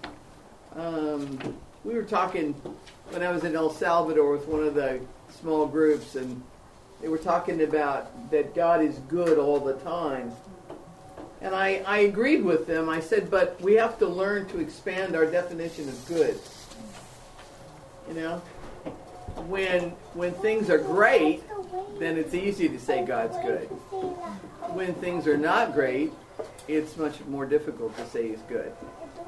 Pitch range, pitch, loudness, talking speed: 150-200 Hz, 170 Hz, -27 LUFS, 150 wpm